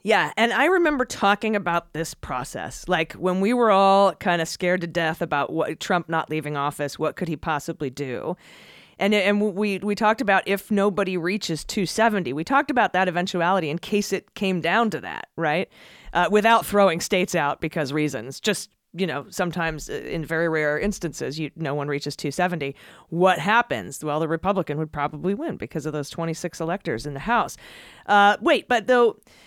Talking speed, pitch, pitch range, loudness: 190 wpm, 175 Hz, 155-205 Hz, -23 LUFS